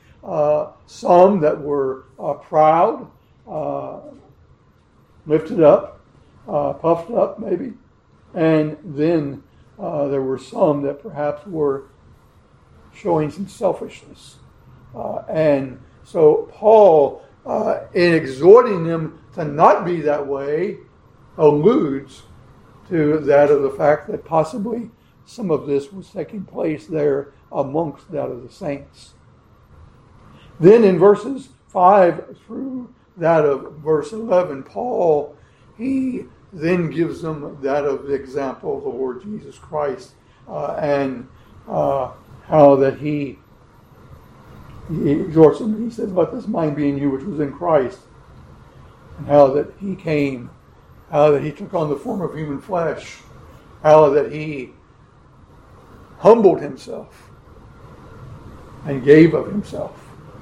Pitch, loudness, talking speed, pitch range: 150 Hz, -18 LUFS, 125 wpm, 140-185 Hz